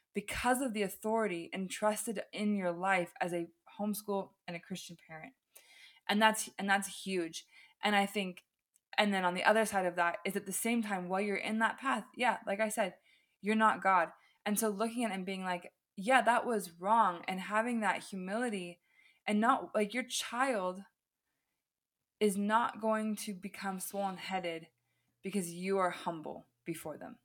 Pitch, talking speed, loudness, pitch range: 200 Hz, 180 wpm, -34 LUFS, 185-220 Hz